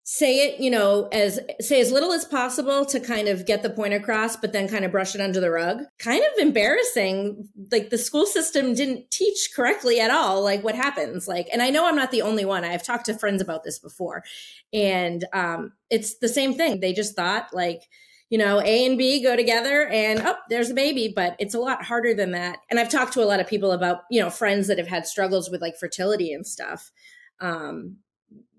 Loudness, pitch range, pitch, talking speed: -23 LUFS, 195-260 Hz, 220 Hz, 225 wpm